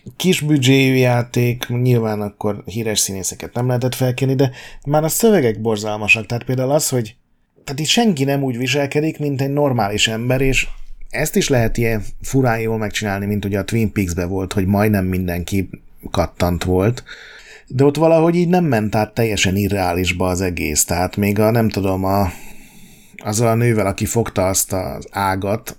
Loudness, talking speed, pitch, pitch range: -18 LUFS, 170 wpm, 110 Hz, 100-130 Hz